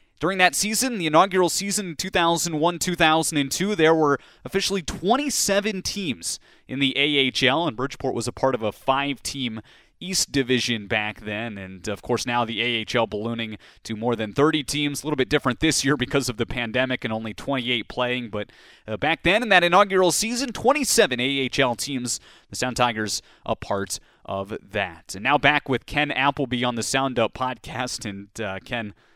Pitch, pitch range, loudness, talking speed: 130 Hz, 115-160 Hz, -23 LUFS, 180 wpm